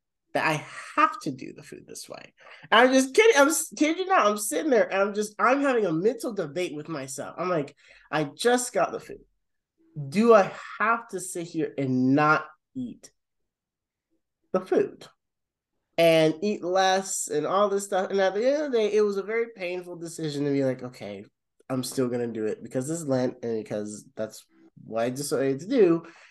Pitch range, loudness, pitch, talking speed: 140-225 Hz, -25 LUFS, 180 Hz, 205 wpm